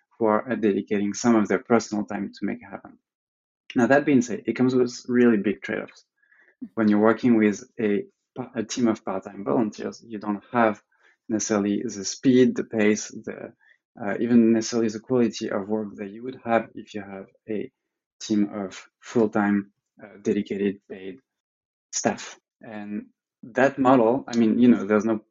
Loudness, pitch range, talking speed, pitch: -23 LUFS, 105-115 Hz, 170 wpm, 110 Hz